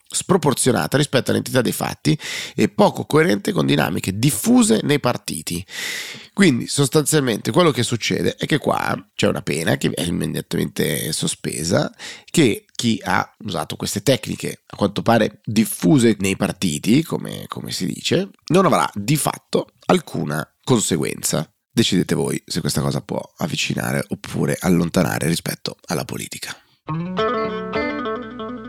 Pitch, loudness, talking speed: 120 Hz, -20 LUFS, 130 wpm